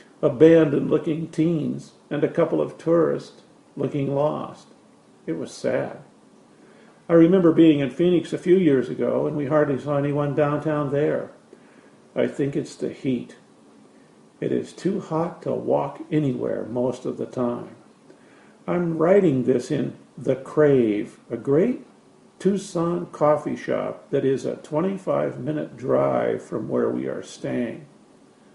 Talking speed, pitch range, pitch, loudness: 140 wpm, 140-165 Hz, 150 Hz, -23 LUFS